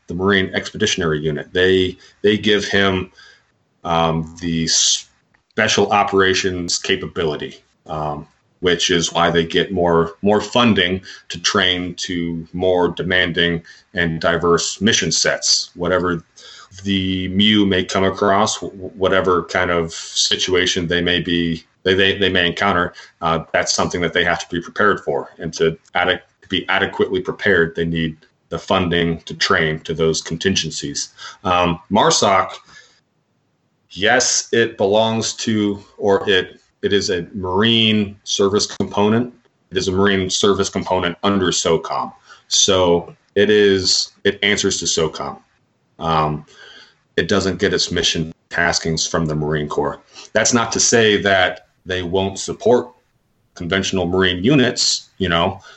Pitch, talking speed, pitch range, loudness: 90 Hz, 140 wpm, 85-95 Hz, -17 LUFS